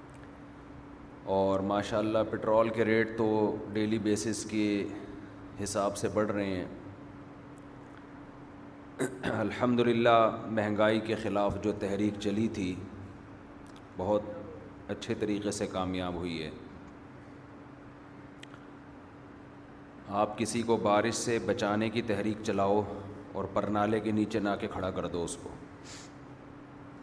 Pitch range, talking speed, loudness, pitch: 100-115 Hz, 115 wpm, -31 LUFS, 105 Hz